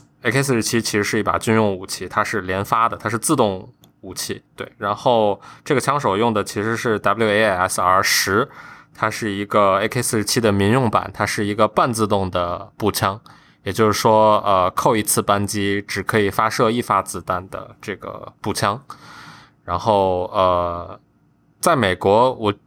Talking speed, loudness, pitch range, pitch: 255 characters per minute, -19 LUFS, 100-115 Hz, 105 Hz